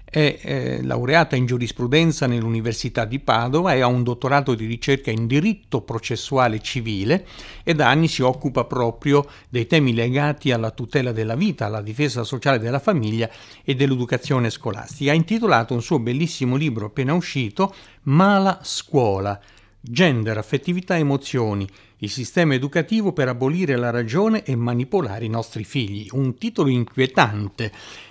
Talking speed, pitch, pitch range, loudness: 145 wpm, 130 Hz, 115-145 Hz, -21 LUFS